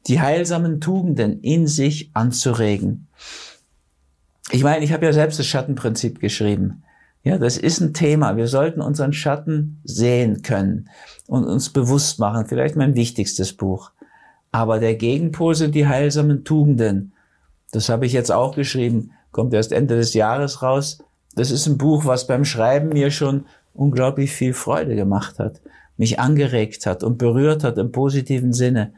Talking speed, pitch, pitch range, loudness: 155 wpm, 130 Hz, 115-150 Hz, -19 LUFS